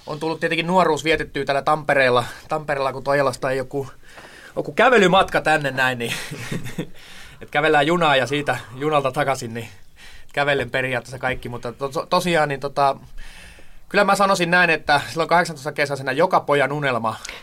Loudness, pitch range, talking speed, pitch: -20 LUFS, 130-155 Hz, 150 wpm, 140 Hz